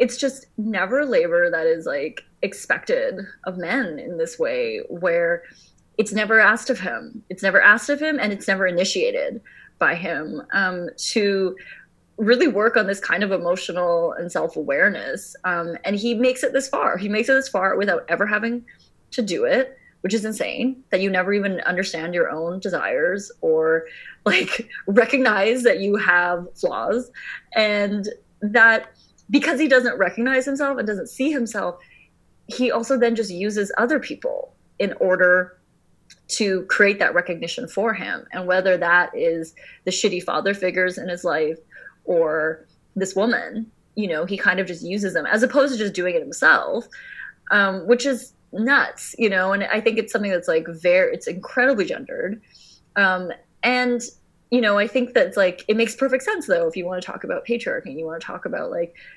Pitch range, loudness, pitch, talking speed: 185-265 Hz, -21 LUFS, 220 Hz, 180 wpm